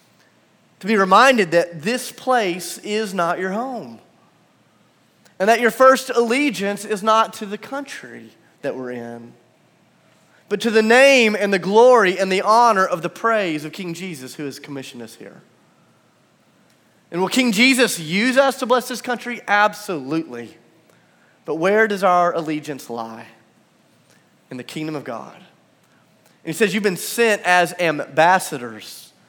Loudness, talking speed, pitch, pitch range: -18 LUFS, 150 wpm, 200 Hz, 165-230 Hz